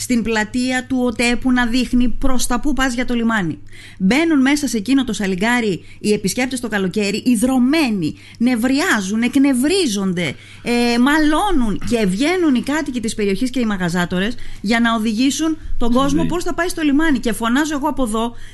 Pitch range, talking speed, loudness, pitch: 220-275 Hz, 170 wpm, -18 LUFS, 245 Hz